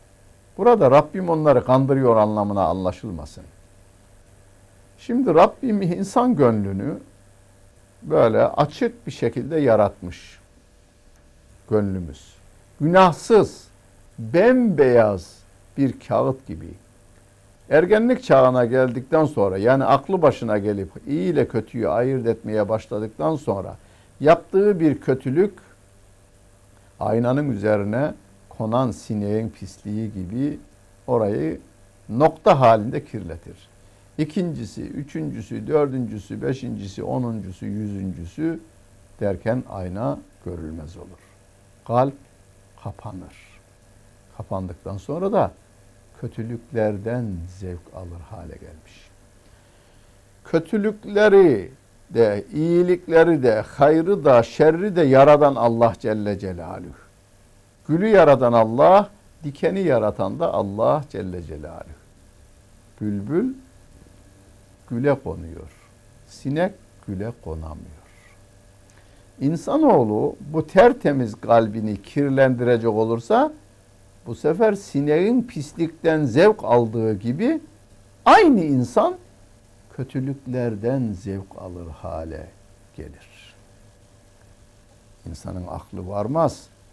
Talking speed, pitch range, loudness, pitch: 80 wpm, 100-135 Hz, -20 LUFS, 105 Hz